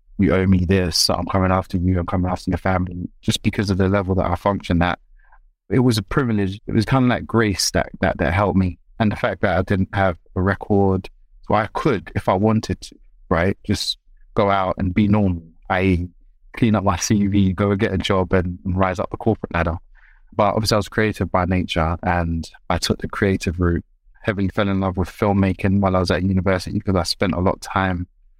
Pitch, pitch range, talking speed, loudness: 95 Hz, 90-105 Hz, 230 wpm, -20 LUFS